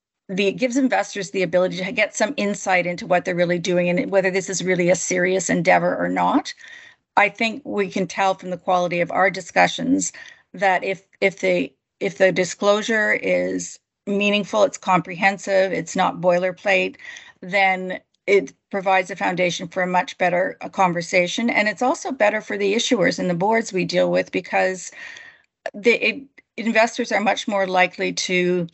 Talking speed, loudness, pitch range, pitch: 170 wpm, -20 LUFS, 180-220 Hz, 195 Hz